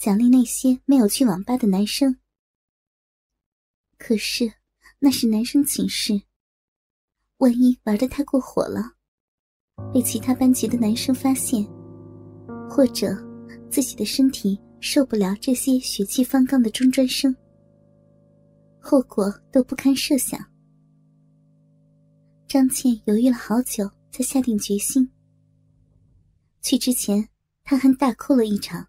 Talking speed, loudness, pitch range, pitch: 180 characters per minute, -21 LUFS, 210-265 Hz, 250 Hz